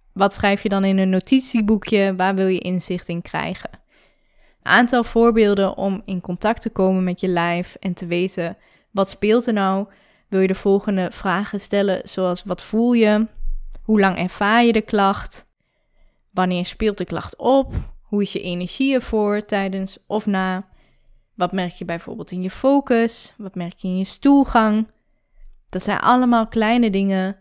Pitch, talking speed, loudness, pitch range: 195 Hz, 170 wpm, -20 LUFS, 185-220 Hz